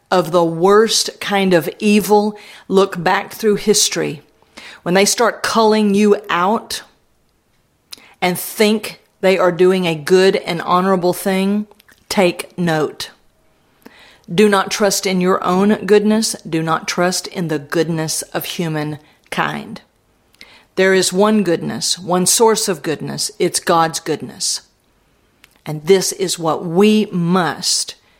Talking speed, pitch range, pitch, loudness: 130 wpm, 175-210 Hz, 190 Hz, -16 LUFS